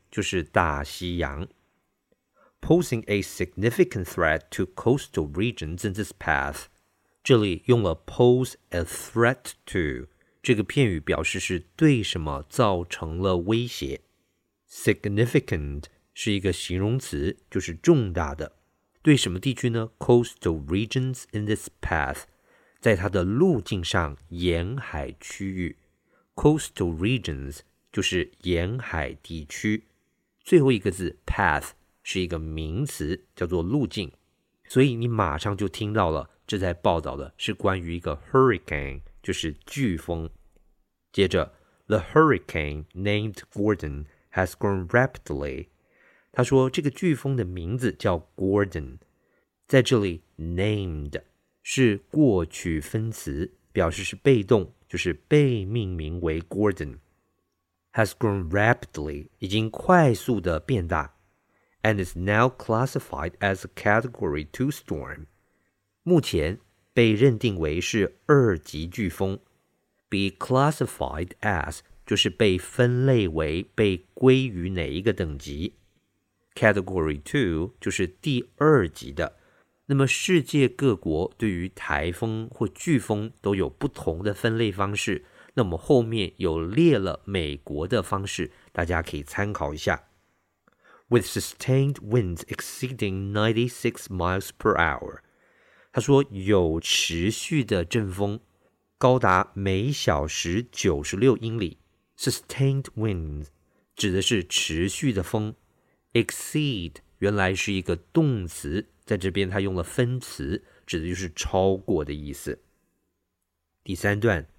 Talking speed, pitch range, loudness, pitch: 165 wpm, 85-120 Hz, -25 LUFS, 100 Hz